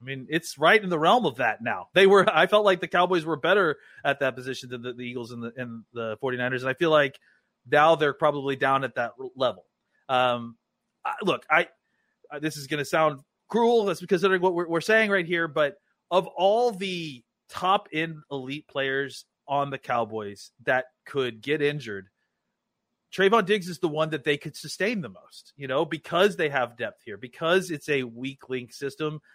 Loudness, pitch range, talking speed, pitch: -25 LUFS, 130-180 Hz, 200 wpm, 150 Hz